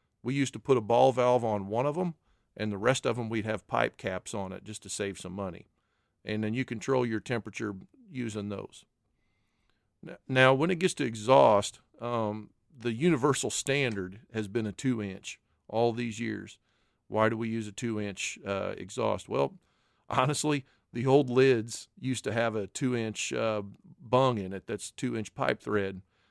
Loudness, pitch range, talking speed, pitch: -30 LUFS, 105-130 Hz, 185 wpm, 115 Hz